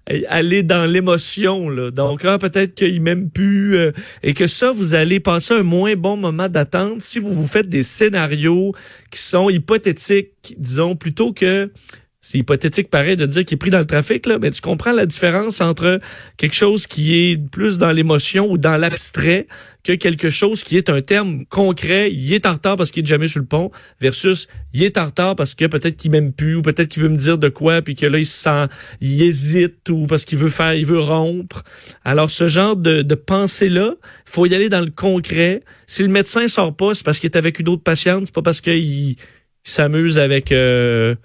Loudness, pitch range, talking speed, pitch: -16 LUFS, 155-190 Hz, 215 wpm, 170 Hz